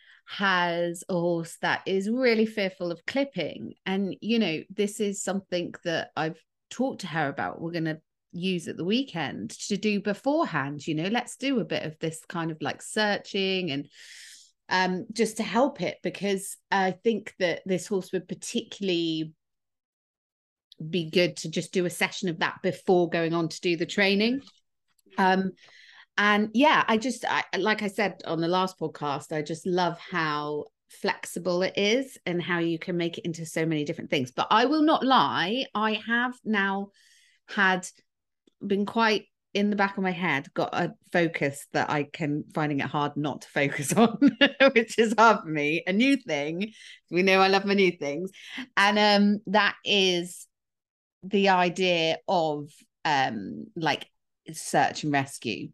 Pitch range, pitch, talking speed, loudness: 165-210 Hz, 185 Hz, 170 wpm, -26 LUFS